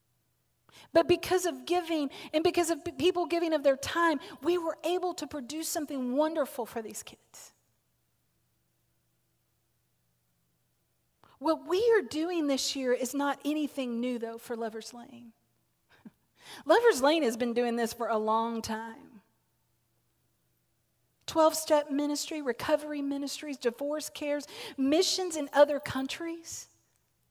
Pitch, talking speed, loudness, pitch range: 290 Hz, 125 wpm, -30 LUFS, 240-325 Hz